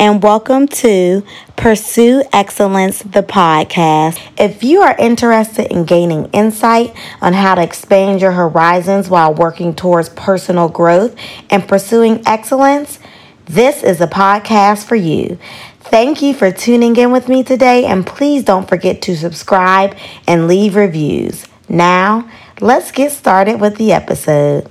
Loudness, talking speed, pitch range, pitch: -11 LUFS, 140 wpm, 180-230 Hz, 200 Hz